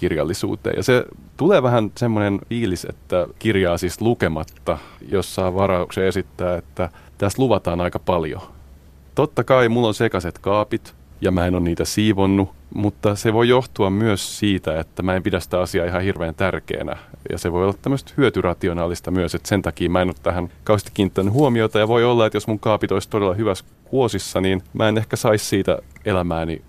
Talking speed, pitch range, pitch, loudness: 180 wpm, 90-110 Hz, 95 Hz, -20 LUFS